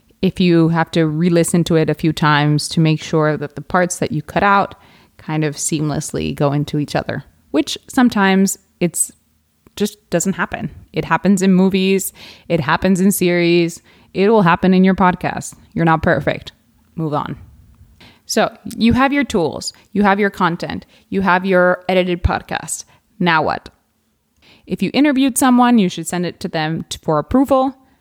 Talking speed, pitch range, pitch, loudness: 175 wpm, 155-195 Hz, 180 Hz, -16 LUFS